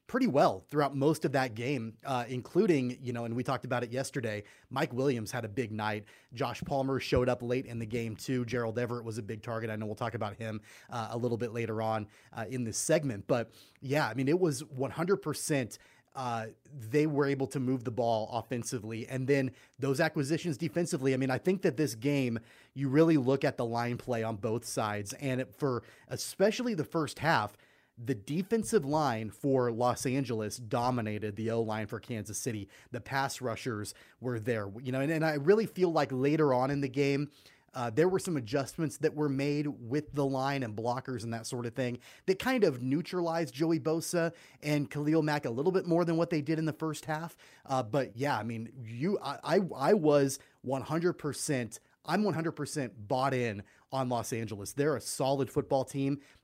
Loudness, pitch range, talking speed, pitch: -32 LUFS, 120-150 Hz, 205 wpm, 130 Hz